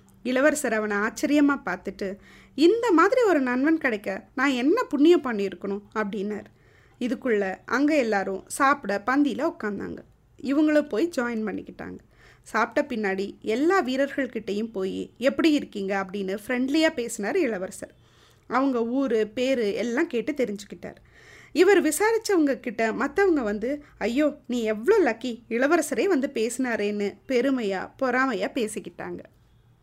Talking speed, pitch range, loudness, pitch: 110 wpm, 210-295 Hz, -25 LUFS, 250 Hz